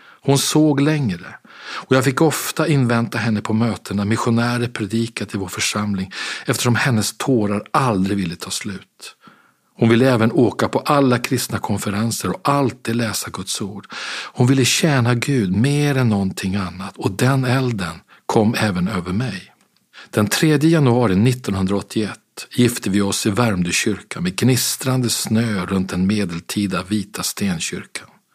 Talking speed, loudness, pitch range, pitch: 145 wpm, -19 LUFS, 100-130 Hz, 115 Hz